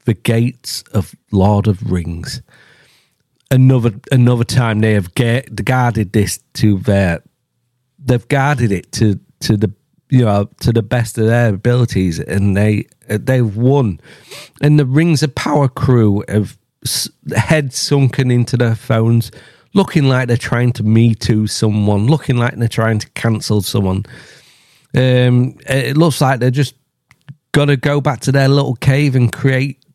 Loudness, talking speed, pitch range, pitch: -15 LUFS, 155 wpm, 110-135 Hz, 120 Hz